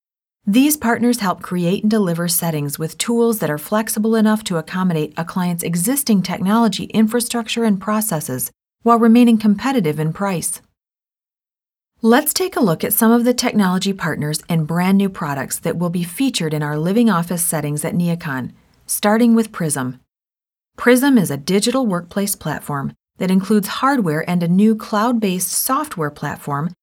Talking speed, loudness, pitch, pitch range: 160 wpm, -17 LUFS, 195 Hz, 165-230 Hz